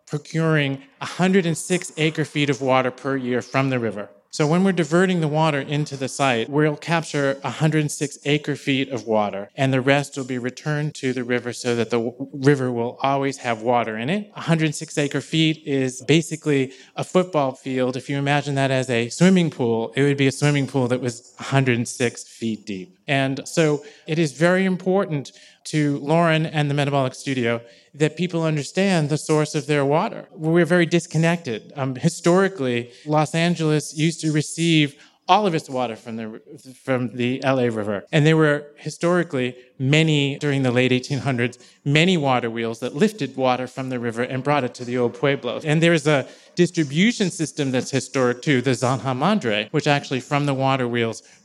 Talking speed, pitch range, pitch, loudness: 180 wpm, 125-155 Hz, 140 Hz, -21 LUFS